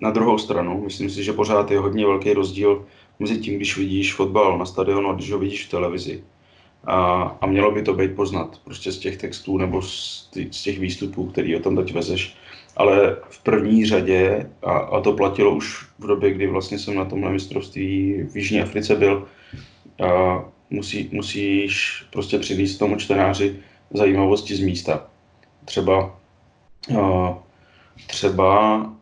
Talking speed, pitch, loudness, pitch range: 160 wpm, 100 Hz, -21 LUFS, 95-100 Hz